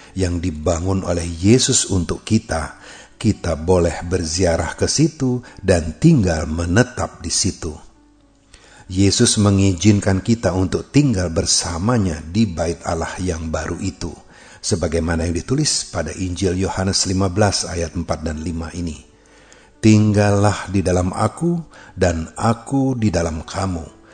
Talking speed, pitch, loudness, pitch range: 120 wpm, 95 Hz, -19 LUFS, 85-105 Hz